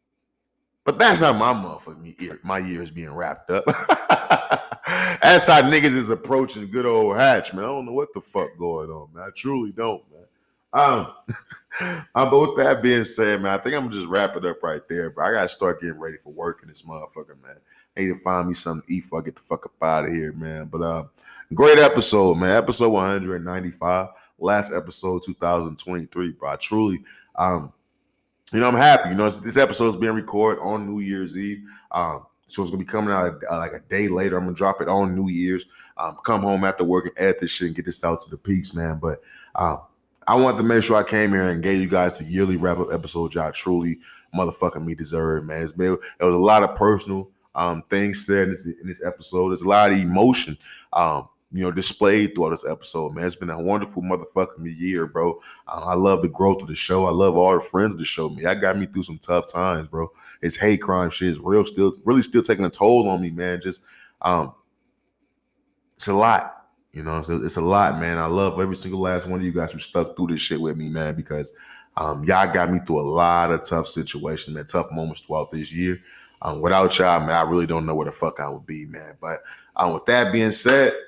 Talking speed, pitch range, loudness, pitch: 230 wpm, 85-100 Hz, -21 LUFS, 90 Hz